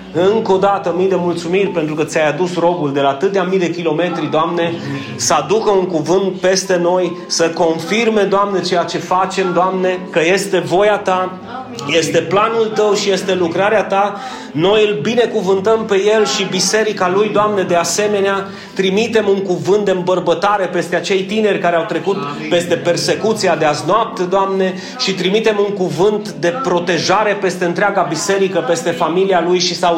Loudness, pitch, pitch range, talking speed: -15 LUFS, 185 Hz, 170-200 Hz, 170 wpm